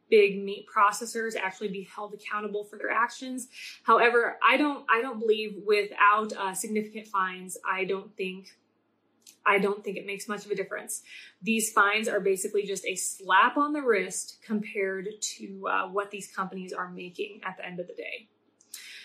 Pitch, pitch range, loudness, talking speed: 210 Hz, 200-235 Hz, -28 LUFS, 175 wpm